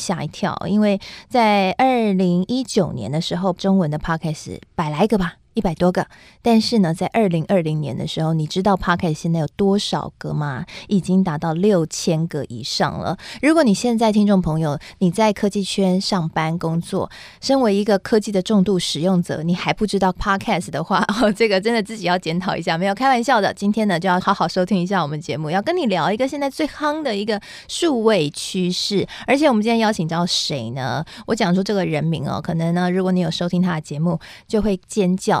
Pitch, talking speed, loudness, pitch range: 190 Hz, 340 characters per minute, -19 LUFS, 165-210 Hz